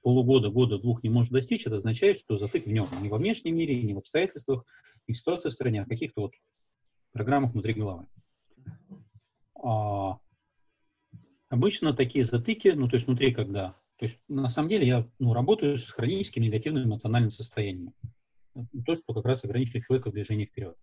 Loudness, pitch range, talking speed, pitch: -28 LUFS, 110-130 Hz, 180 wpm, 120 Hz